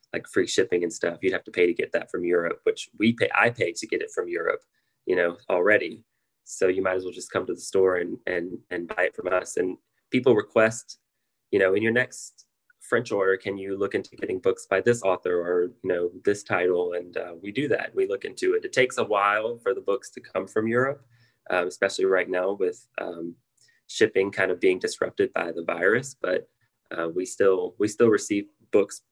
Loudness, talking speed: -25 LUFS, 225 wpm